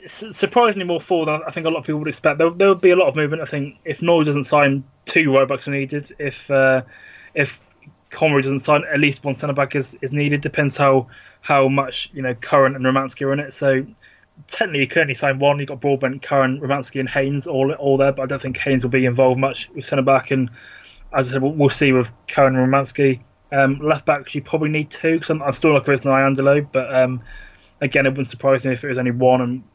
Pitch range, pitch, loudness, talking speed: 135-150 Hz, 140 Hz, -18 LUFS, 250 wpm